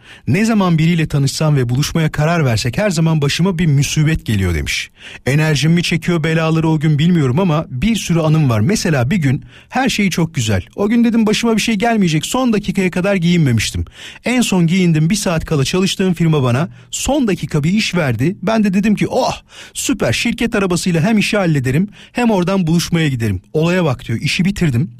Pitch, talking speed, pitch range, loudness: 170 Hz, 190 wpm, 145-195 Hz, -15 LUFS